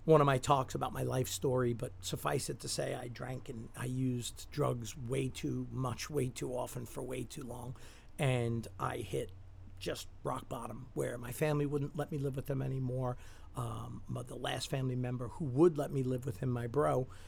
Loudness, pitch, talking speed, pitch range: -37 LUFS, 125 Hz, 210 wpm, 120-135 Hz